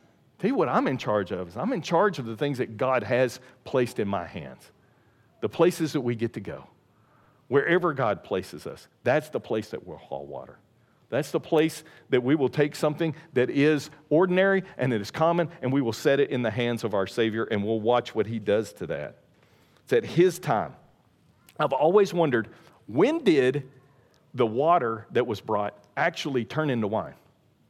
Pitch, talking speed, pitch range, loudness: 130 Hz, 195 wpm, 115-155 Hz, -26 LUFS